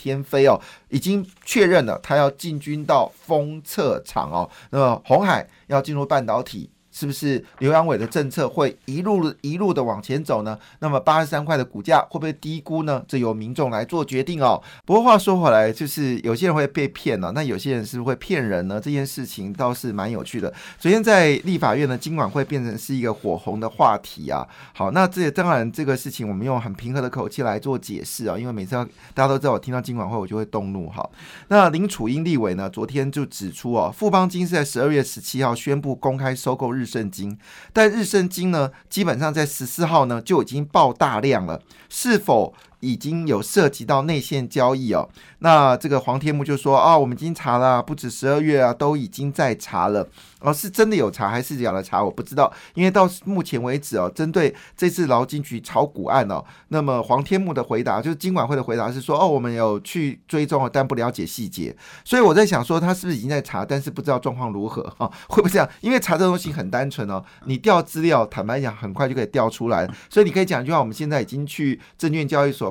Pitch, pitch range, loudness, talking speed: 140 Hz, 125-160 Hz, -21 LUFS, 335 characters per minute